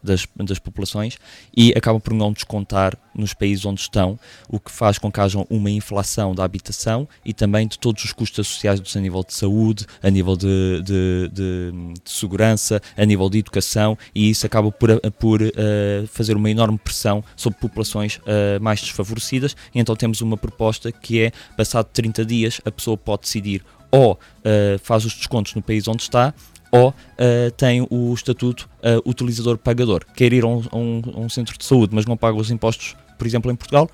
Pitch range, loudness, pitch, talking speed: 100-115 Hz, -19 LUFS, 110 Hz, 190 wpm